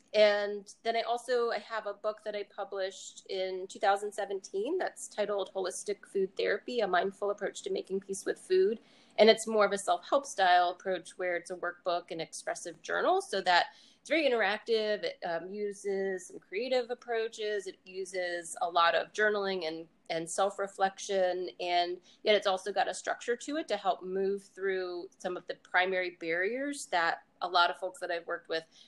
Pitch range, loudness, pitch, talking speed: 180-225 Hz, -32 LUFS, 195 Hz, 185 wpm